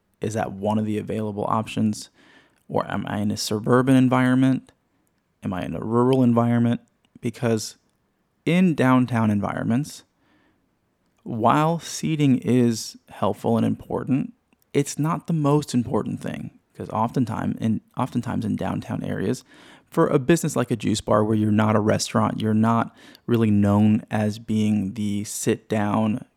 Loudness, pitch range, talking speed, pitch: -23 LUFS, 105-130 Hz, 145 wpm, 115 Hz